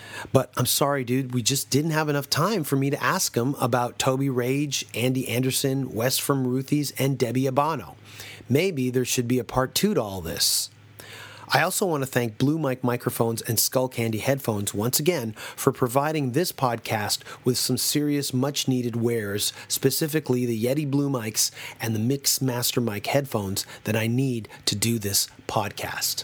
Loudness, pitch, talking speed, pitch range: -24 LUFS, 130 Hz, 180 wpm, 115-140 Hz